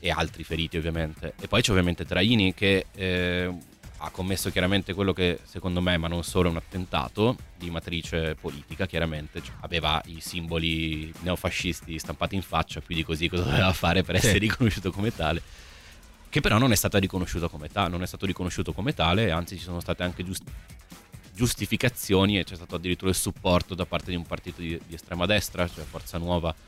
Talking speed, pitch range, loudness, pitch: 190 wpm, 80-95 Hz, -27 LUFS, 90 Hz